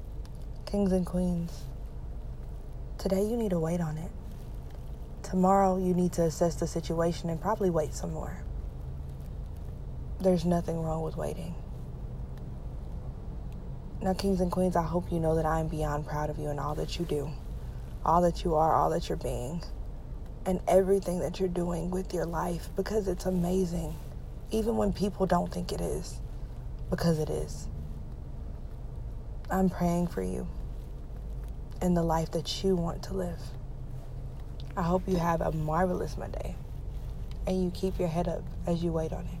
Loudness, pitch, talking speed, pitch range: -31 LUFS, 170 Hz, 160 wpm, 145-185 Hz